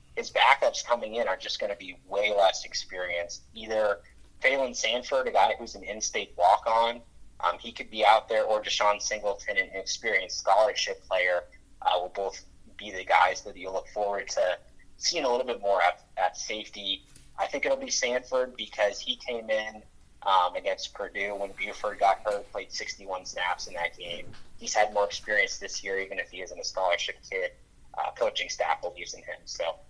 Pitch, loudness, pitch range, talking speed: 105 Hz, -28 LUFS, 100-155 Hz, 190 wpm